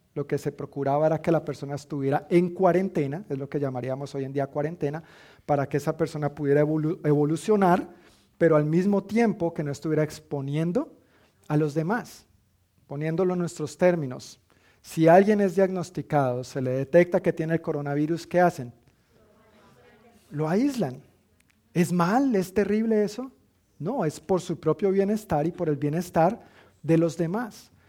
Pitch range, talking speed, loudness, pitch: 145-180 Hz, 160 wpm, -25 LUFS, 155 Hz